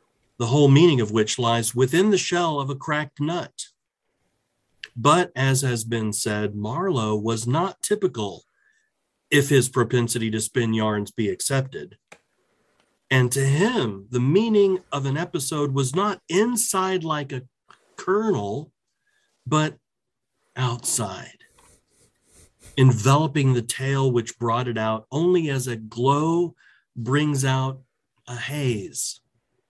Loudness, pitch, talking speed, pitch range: -22 LUFS, 130 Hz, 125 wpm, 120-155 Hz